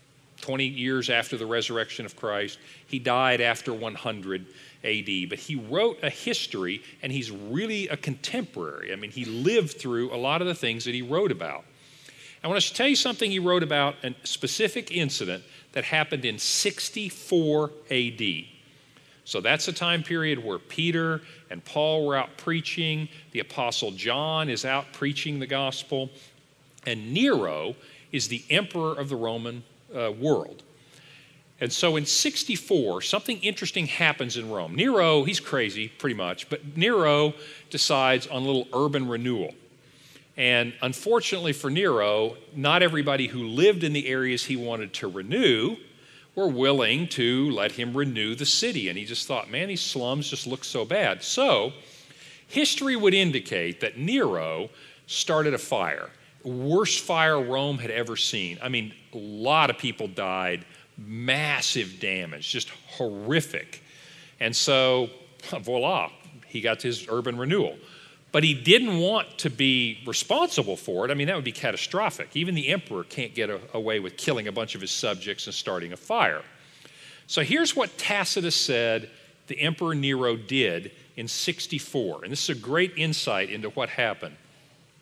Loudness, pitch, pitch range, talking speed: -26 LUFS, 140 Hz, 125-160 Hz, 160 wpm